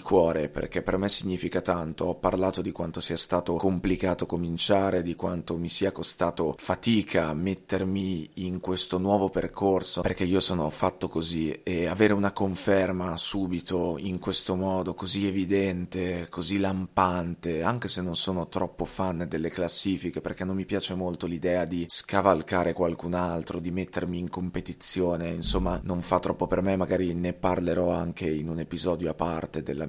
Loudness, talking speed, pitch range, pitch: -27 LUFS, 160 wpm, 85-95 Hz, 90 Hz